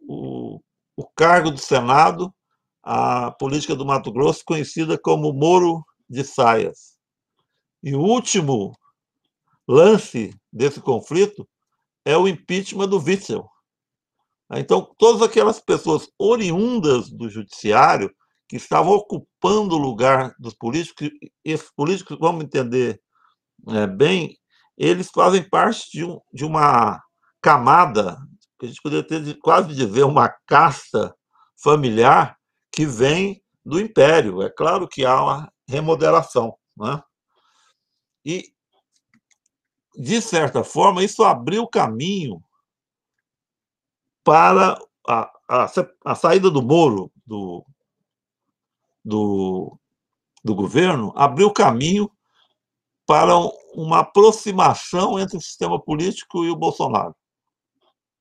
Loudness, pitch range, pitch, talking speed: -18 LUFS, 135-195 Hz, 160 Hz, 110 wpm